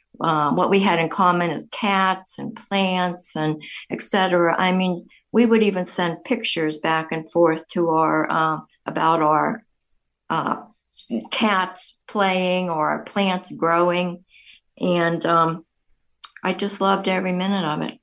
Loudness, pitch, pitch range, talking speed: -21 LUFS, 180 Hz, 165-190 Hz, 145 wpm